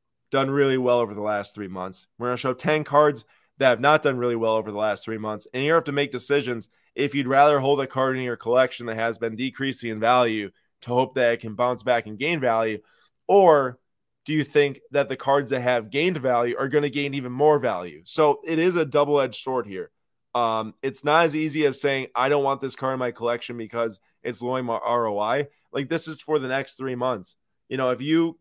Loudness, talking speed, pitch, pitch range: -23 LUFS, 235 wpm, 130 Hz, 115-145 Hz